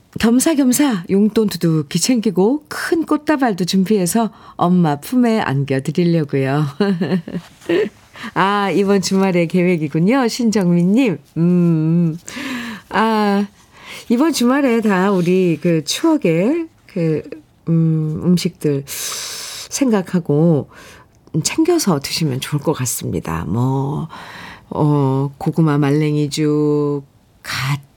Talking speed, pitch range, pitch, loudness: 200 characters per minute, 150-220 Hz, 180 Hz, -17 LUFS